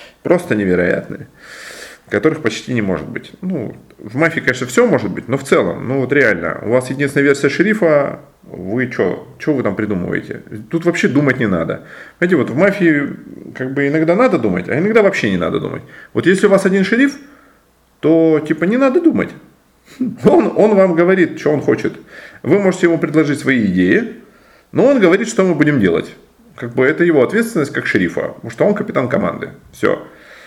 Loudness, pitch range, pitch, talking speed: -15 LUFS, 135-190 Hz, 160 Hz, 185 wpm